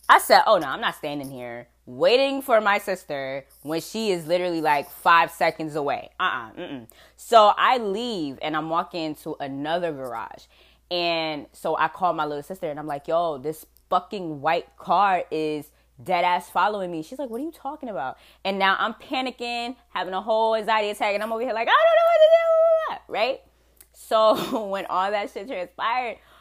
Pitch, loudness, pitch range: 180 Hz, -23 LUFS, 155-225 Hz